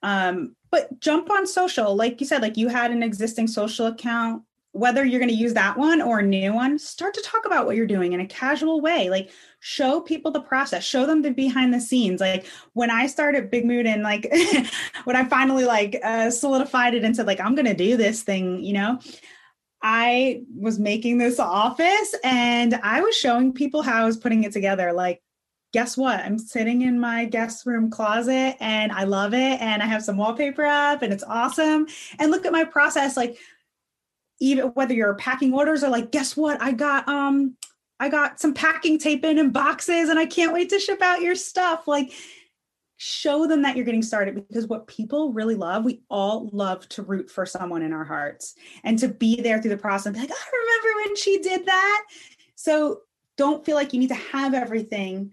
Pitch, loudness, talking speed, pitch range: 250 Hz, -22 LUFS, 210 wpm, 220-295 Hz